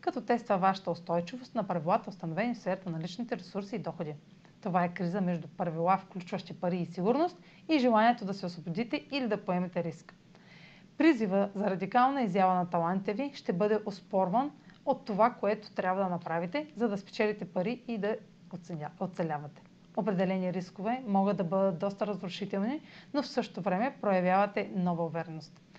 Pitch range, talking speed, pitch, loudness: 180-220 Hz, 160 wpm, 195 Hz, -32 LUFS